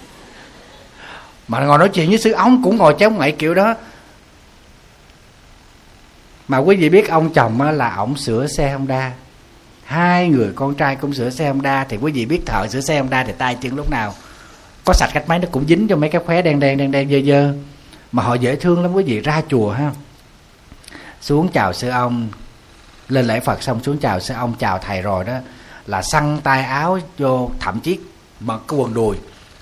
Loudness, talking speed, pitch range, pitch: -17 LUFS, 205 wpm, 115-150 Hz, 135 Hz